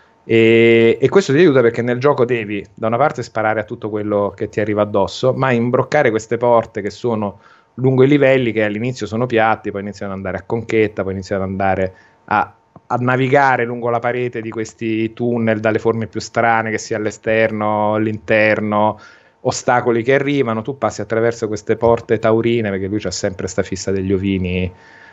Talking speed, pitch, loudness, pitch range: 185 wpm, 110 Hz, -17 LUFS, 105-120 Hz